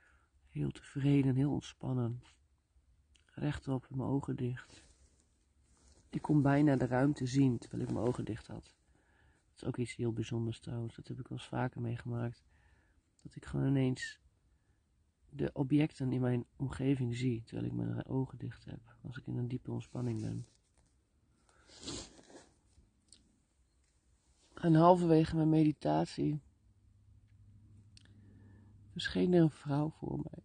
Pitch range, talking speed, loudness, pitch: 80-130 Hz, 135 wpm, -35 LUFS, 105 Hz